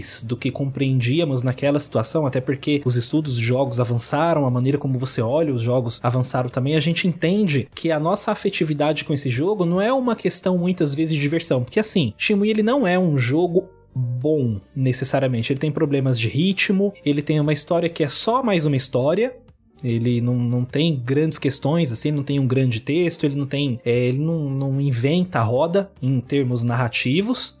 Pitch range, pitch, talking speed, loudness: 130-165 Hz, 140 Hz, 195 wpm, -21 LUFS